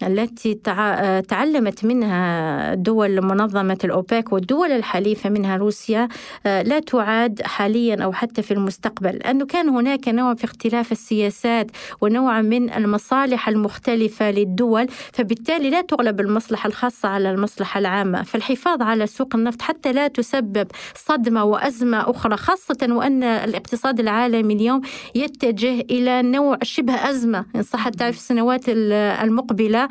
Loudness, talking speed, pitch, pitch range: -20 LUFS, 130 wpm, 230 Hz, 210-255 Hz